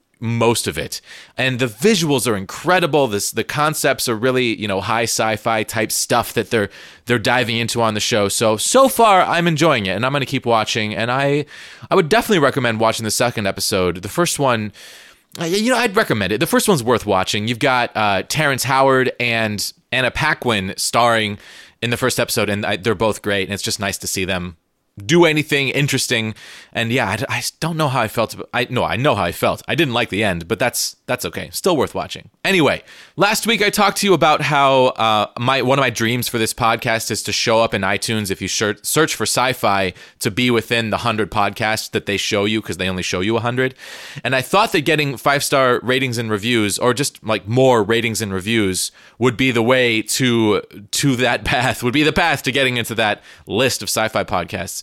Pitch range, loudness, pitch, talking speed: 105-135 Hz, -17 LUFS, 120 Hz, 220 wpm